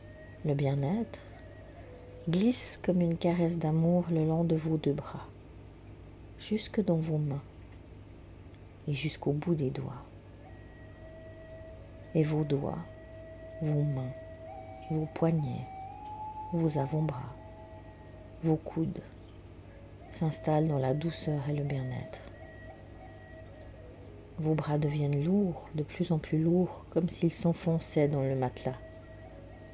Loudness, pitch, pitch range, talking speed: -32 LUFS, 135 Hz, 105-160 Hz, 110 wpm